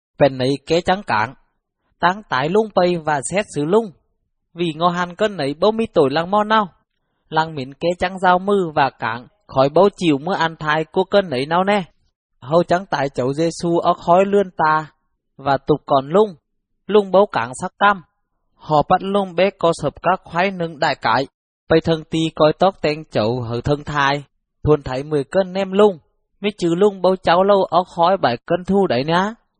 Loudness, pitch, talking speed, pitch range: -18 LUFS, 170 Hz, 205 wpm, 145-190 Hz